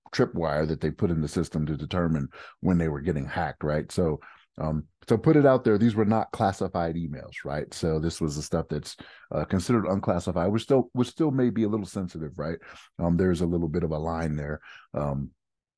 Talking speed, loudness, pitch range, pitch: 215 wpm, -27 LUFS, 80-105 Hz, 85 Hz